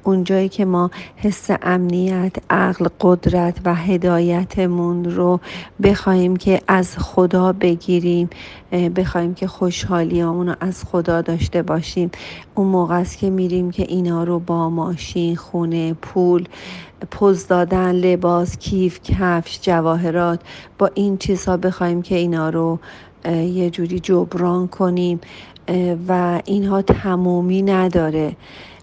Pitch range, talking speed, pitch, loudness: 175-185 Hz, 115 wpm, 180 Hz, -18 LUFS